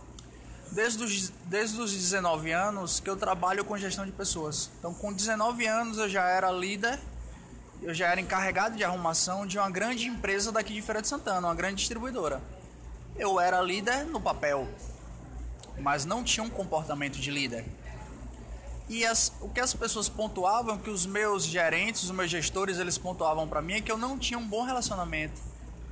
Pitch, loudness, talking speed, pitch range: 185 Hz, -29 LUFS, 180 wpm, 150-215 Hz